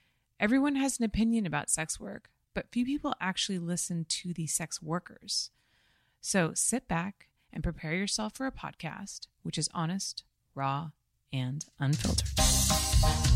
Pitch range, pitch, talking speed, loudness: 140-205 Hz, 170 Hz, 140 wpm, -31 LUFS